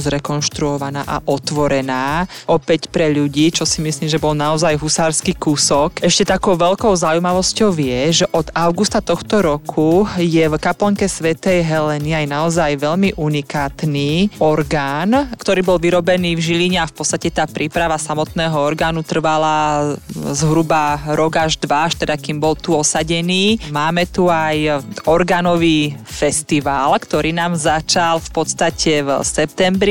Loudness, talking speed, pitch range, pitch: -16 LUFS, 140 wpm, 150-175 Hz, 160 Hz